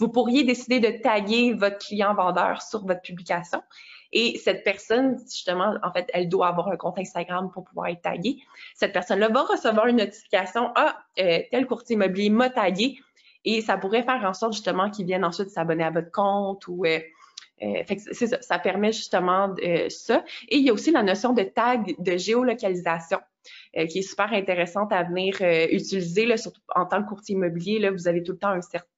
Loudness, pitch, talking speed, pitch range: -24 LUFS, 200 Hz, 205 wpm, 180-230 Hz